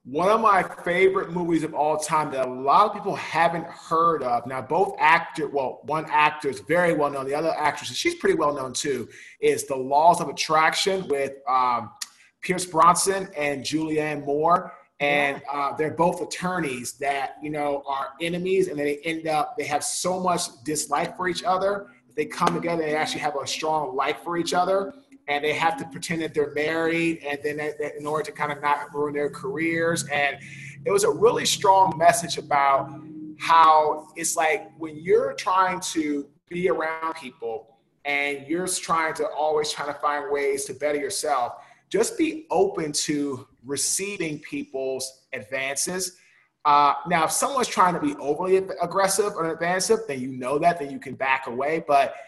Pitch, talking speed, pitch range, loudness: 155 Hz, 180 wpm, 145-180 Hz, -24 LUFS